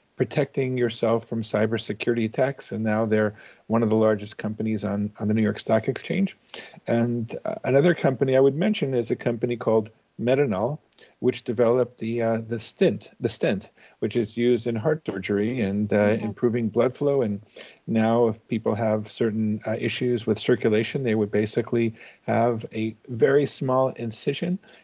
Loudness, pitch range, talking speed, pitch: -24 LUFS, 110-125 Hz, 165 wpm, 115 Hz